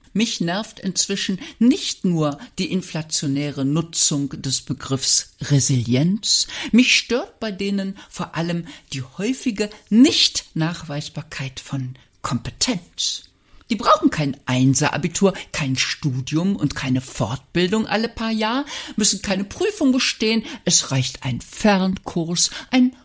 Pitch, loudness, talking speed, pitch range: 175 Hz, -20 LUFS, 110 wpm, 140-220 Hz